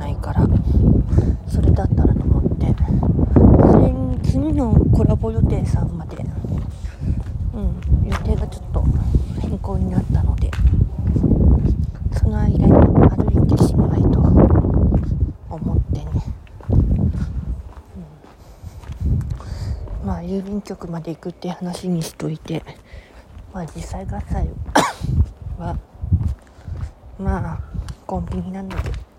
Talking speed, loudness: 195 characters per minute, -19 LUFS